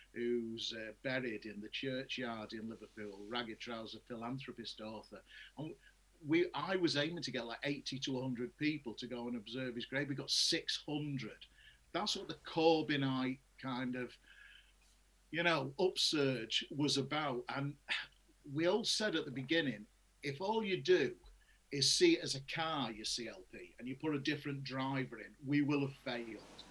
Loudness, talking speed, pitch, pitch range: -38 LUFS, 165 wpm, 135 Hz, 120-150 Hz